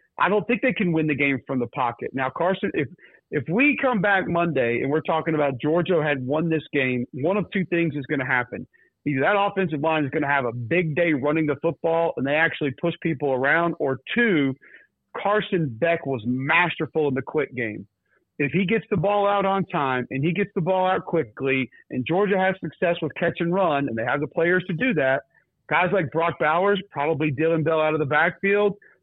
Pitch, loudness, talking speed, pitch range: 165 Hz, -23 LUFS, 225 wpm, 145-185 Hz